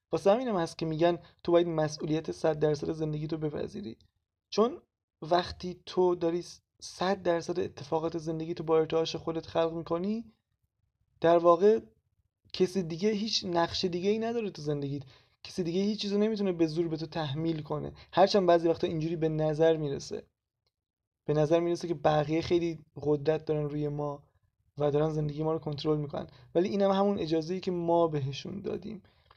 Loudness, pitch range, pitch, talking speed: -30 LUFS, 150-175 Hz, 165 Hz, 170 wpm